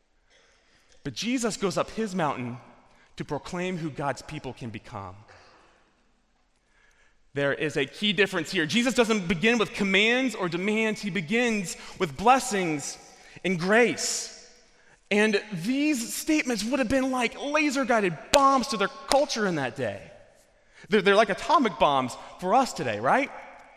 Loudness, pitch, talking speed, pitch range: -25 LUFS, 210 Hz, 145 wpm, 175-240 Hz